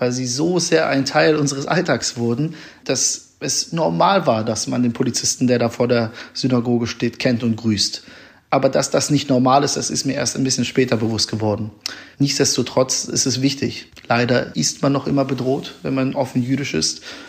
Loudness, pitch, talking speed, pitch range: -19 LUFS, 125 Hz, 195 wpm, 115-135 Hz